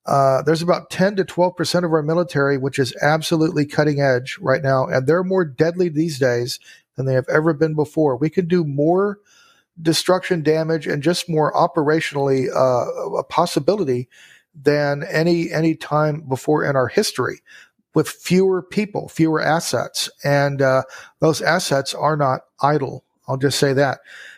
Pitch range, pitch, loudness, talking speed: 140-170 Hz, 155 Hz, -19 LUFS, 160 wpm